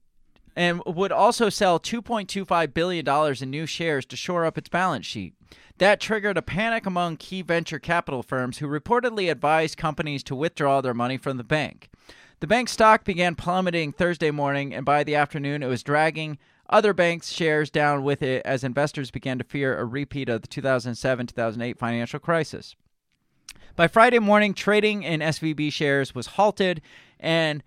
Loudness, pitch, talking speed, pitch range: -23 LUFS, 155 Hz, 170 wpm, 135-180 Hz